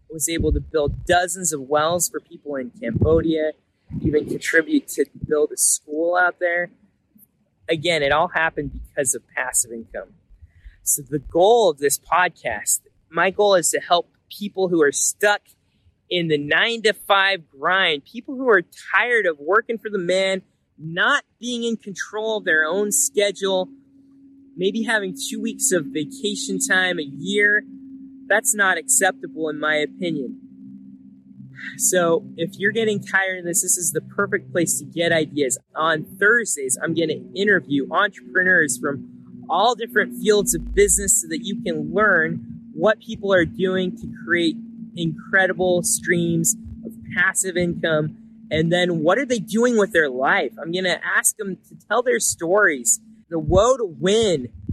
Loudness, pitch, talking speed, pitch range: -20 LUFS, 185 Hz, 160 wpm, 155-220 Hz